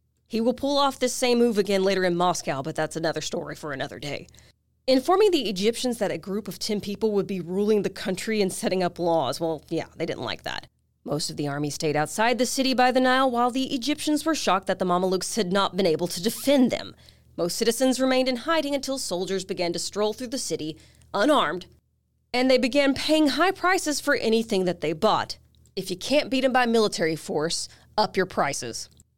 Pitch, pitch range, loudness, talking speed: 210 Hz, 175-260 Hz, -24 LUFS, 215 wpm